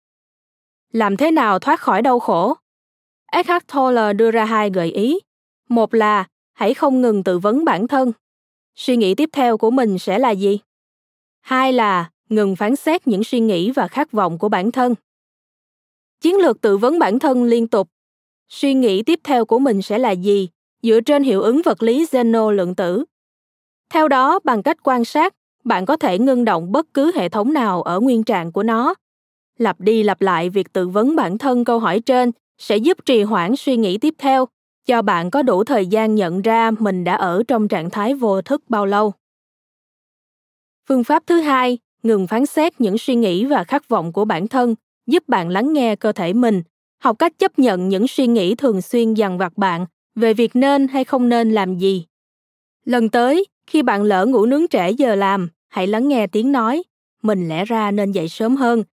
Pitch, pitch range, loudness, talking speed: 230 Hz, 205-270 Hz, -17 LUFS, 200 wpm